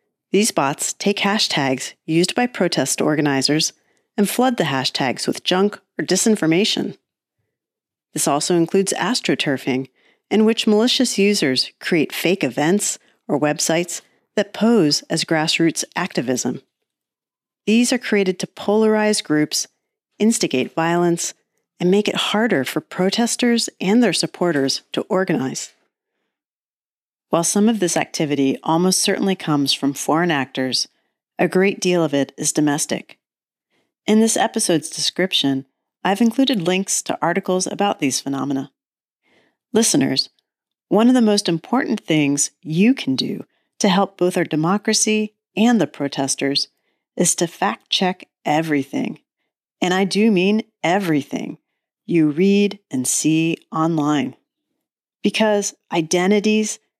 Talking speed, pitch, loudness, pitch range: 125 wpm, 185 Hz, -19 LUFS, 155-215 Hz